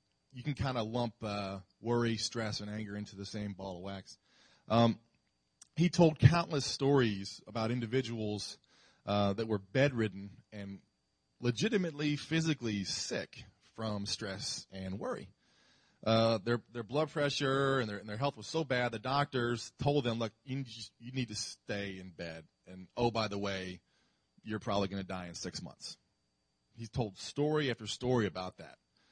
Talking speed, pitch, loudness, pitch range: 165 wpm, 115 Hz, -35 LUFS, 100-130 Hz